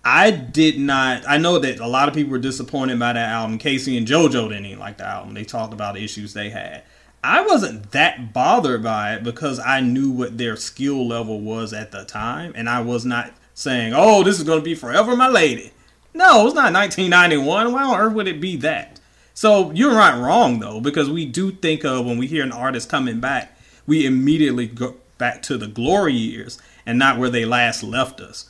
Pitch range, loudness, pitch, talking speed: 120-160 Hz, -18 LUFS, 130 Hz, 220 wpm